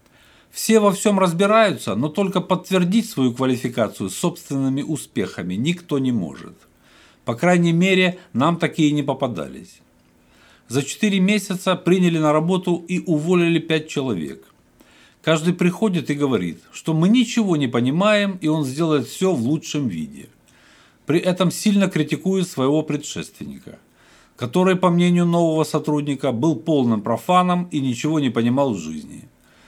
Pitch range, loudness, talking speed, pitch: 140-185 Hz, -20 LUFS, 135 wpm, 160 Hz